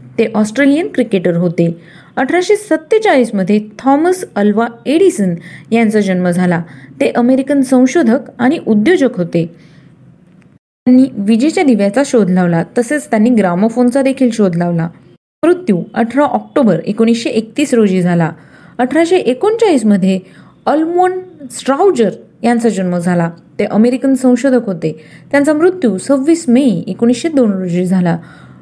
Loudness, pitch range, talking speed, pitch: -12 LUFS, 180-270 Hz, 115 wpm, 230 Hz